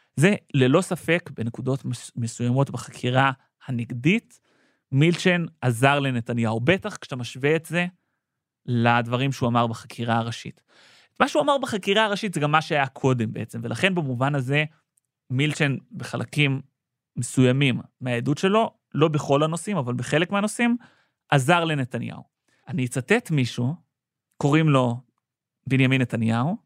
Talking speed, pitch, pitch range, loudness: 120 wpm, 140 Hz, 125-165 Hz, -23 LUFS